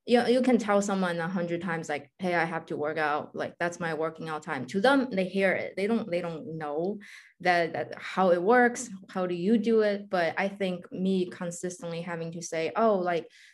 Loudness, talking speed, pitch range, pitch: -28 LUFS, 230 wpm, 165-200 Hz, 180 Hz